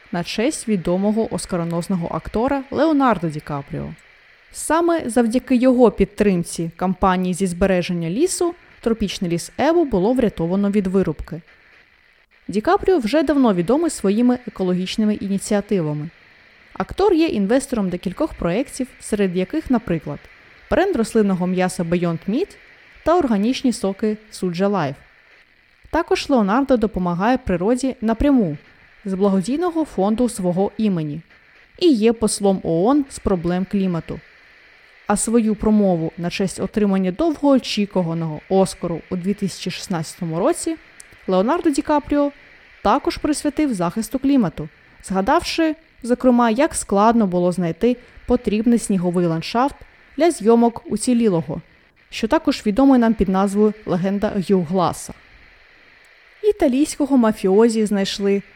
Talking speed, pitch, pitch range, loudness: 110 wpm, 210 Hz, 185-260 Hz, -19 LUFS